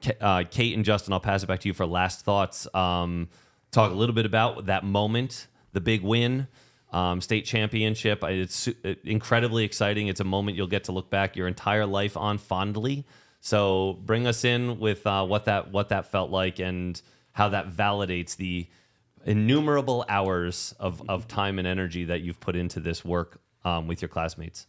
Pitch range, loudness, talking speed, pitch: 90-110 Hz, -27 LUFS, 185 wpm, 100 Hz